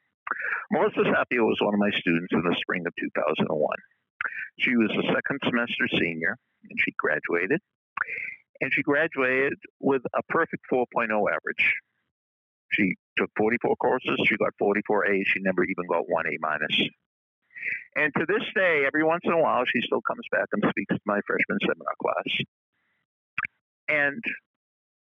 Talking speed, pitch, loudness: 160 wpm, 105 Hz, -26 LUFS